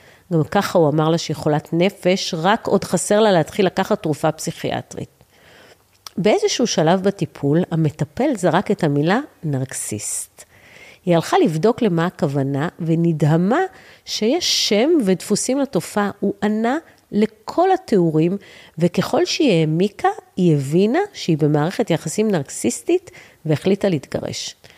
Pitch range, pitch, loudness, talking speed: 160-210 Hz, 180 Hz, -19 LUFS, 120 wpm